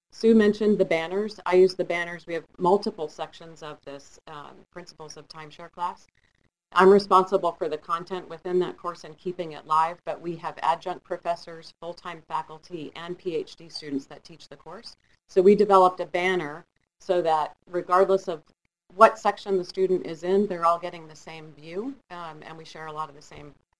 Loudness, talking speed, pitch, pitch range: -24 LUFS, 190 wpm, 175 Hz, 160-185 Hz